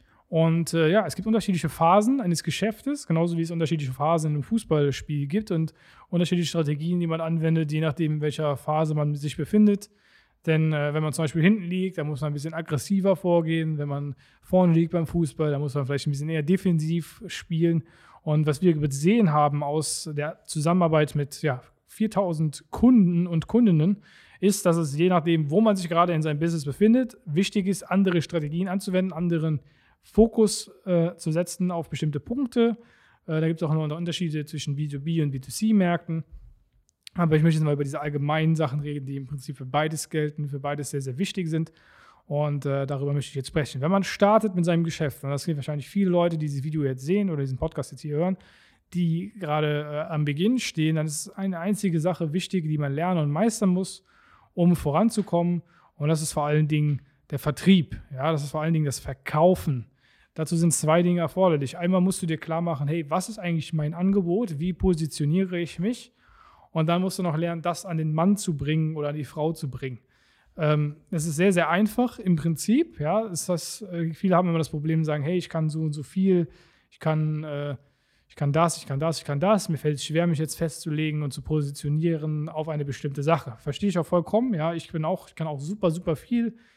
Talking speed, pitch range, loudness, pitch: 210 wpm, 150-180 Hz, -25 LUFS, 165 Hz